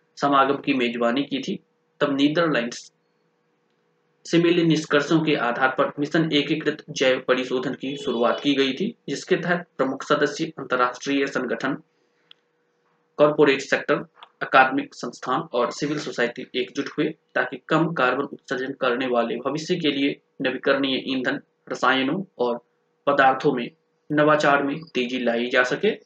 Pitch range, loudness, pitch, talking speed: 130-150 Hz, -23 LUFS, 140 Hz, 135 wpm